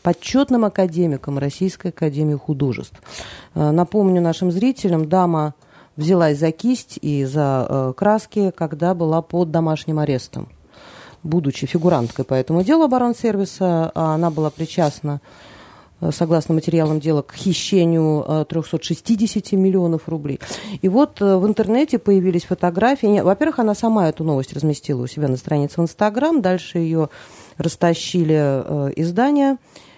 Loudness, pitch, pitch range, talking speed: -19 LUFS, 170 Hz, 155-195 Hz, 125 wpm